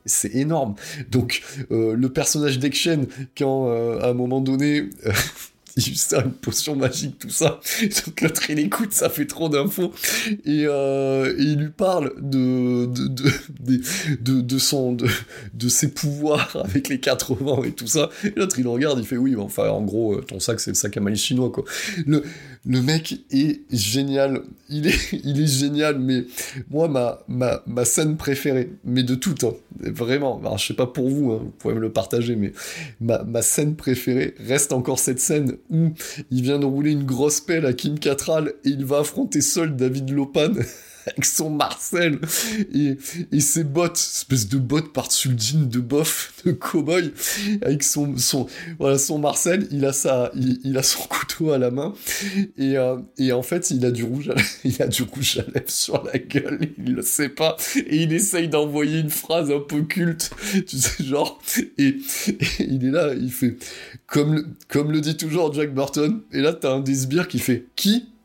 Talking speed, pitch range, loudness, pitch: 195 wpm, 130-155 Hz, -22 LUFS, 140 Hz